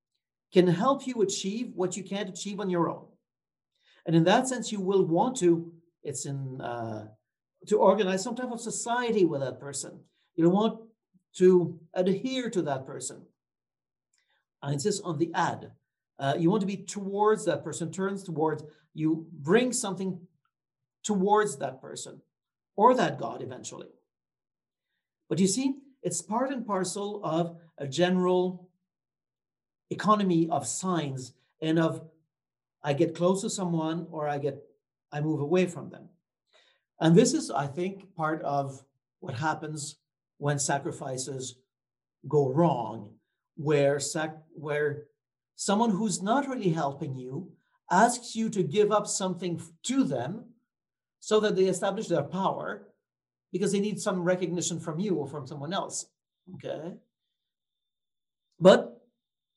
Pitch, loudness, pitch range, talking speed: 175 Hz, -28 LUFS, 150-200 Hz, 140 wpm